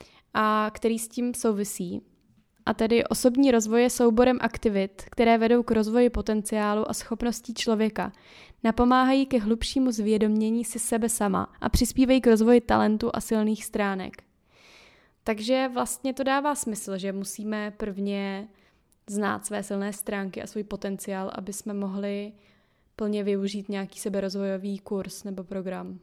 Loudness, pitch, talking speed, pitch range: -26 LUFS, 215 Hz, 140 wpm, 200-235 Hz